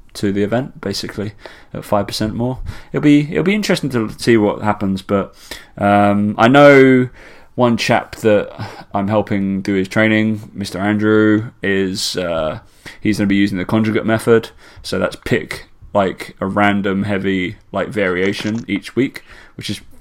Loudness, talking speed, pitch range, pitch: -16 LUFS, 160 wpm, 100-115 Hz, 105 Hz